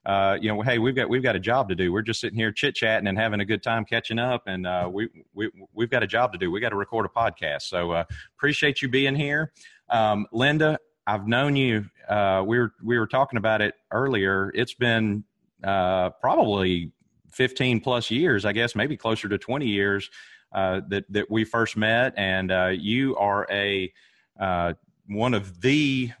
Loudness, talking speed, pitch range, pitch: -24 LUFS, 205 wpm, 100-125 Hz, 110 Hz